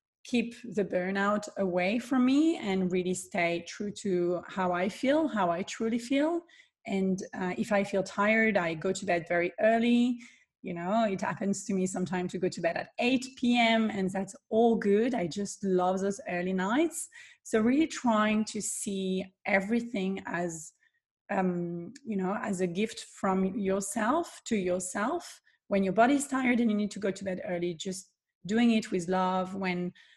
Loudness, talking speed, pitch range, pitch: -30 LUFS, 175 wpm, 185-235 Hz, 200 Hz